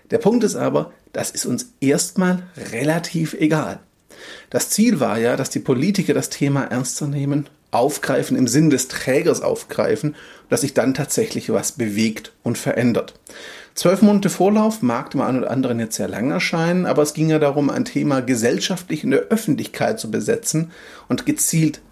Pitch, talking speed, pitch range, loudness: 155 Hz, 170 wpm, 140-185 Hz, -20 LUFS